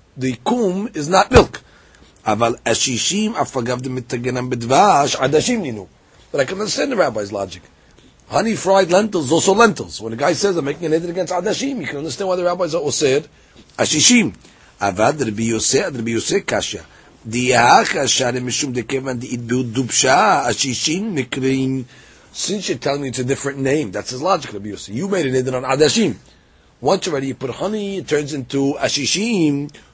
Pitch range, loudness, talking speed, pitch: 125-180 Hz, -18 LUFS, 125 wpm, 135 Hz